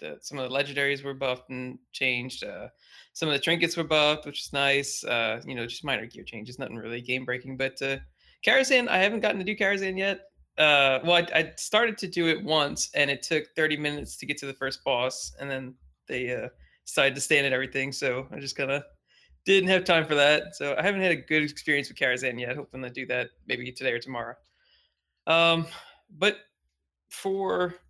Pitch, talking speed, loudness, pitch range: 140 Hz, 215 wpm, -26 LUFS, 125-165 Hz